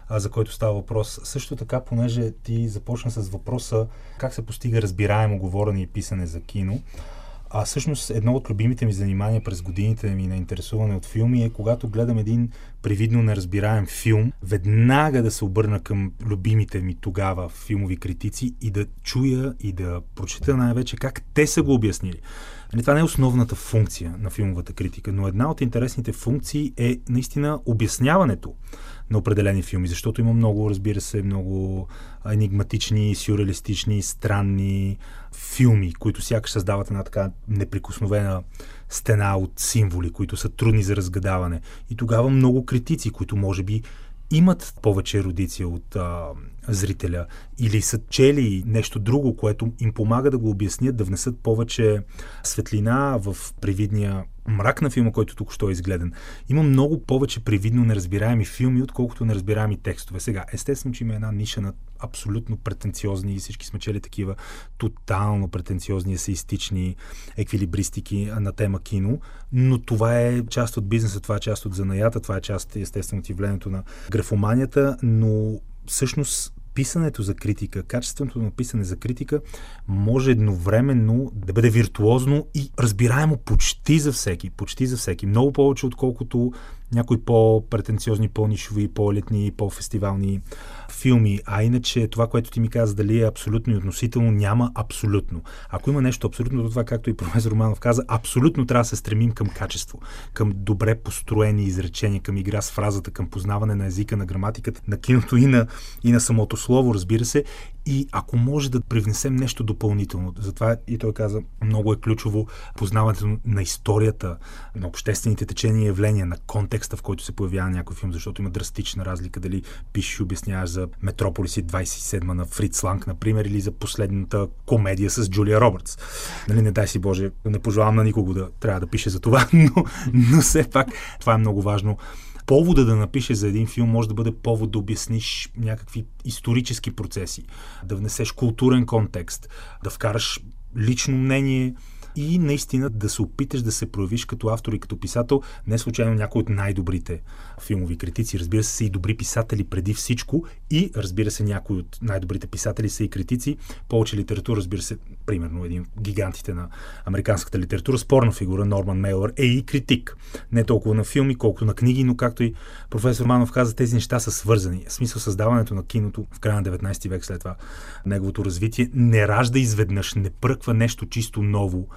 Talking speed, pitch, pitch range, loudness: 165 wpm, 110 Hz, 100-120 Hz, -23 LUFS